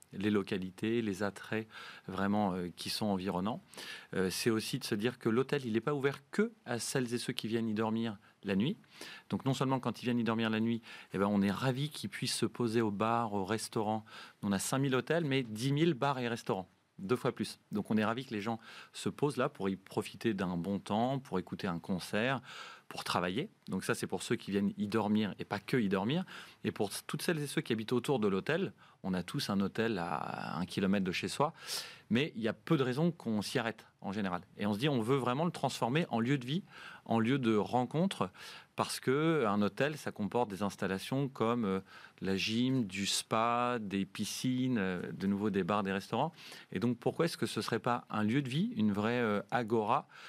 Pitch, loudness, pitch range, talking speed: 115 Hz, -35 LUFS, 100-130 Hz, 230 wpm